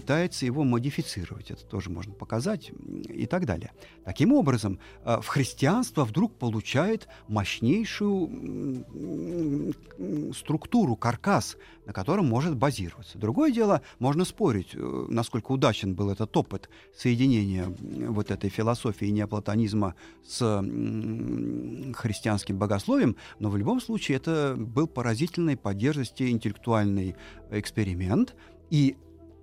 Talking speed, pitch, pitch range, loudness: 105 wpm, 115 Hz, 100-145 Hz, -28 LUFS